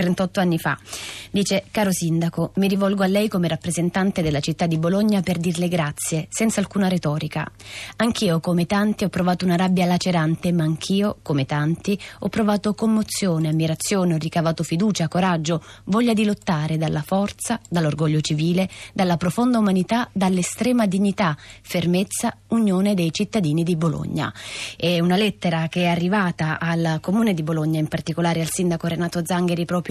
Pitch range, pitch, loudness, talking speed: 165-195 Hz, 175 Hz, -21 LUFS, 155 wpm